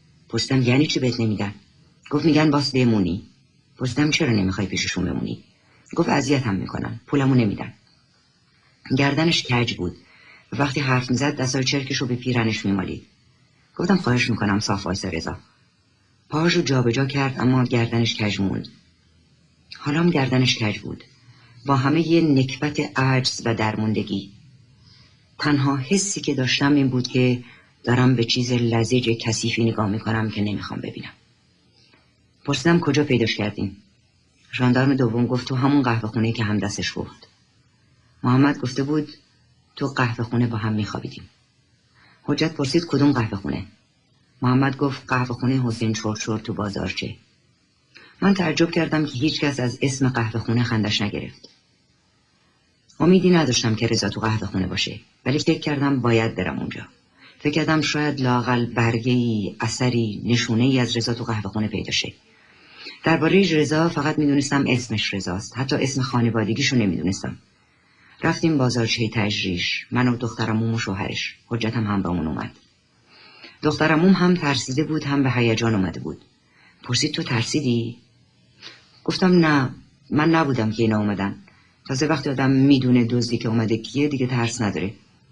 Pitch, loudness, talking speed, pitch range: 125 Hz, -21 LUFS, 140 wpm, 110-140 Hz